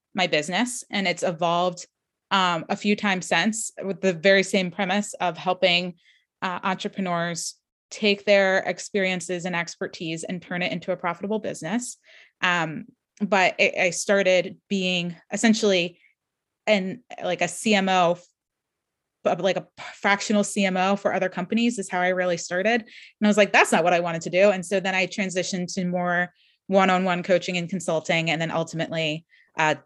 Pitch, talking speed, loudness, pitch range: 185 Hz, 165 wpm, -23 LUFS, 175-200 Hz